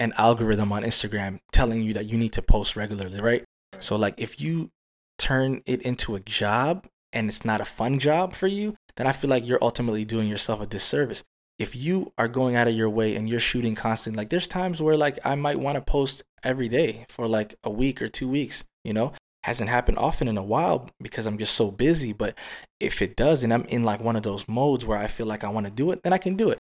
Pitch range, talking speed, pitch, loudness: 110-135 Hz, 250 wpm, 115 Hz, -25 LUFS